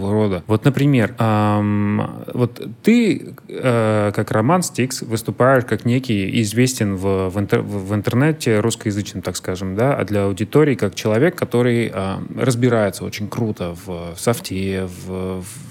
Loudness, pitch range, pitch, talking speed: -19 LUFS, 100-120 Hz, 110 Hz, 150 wpm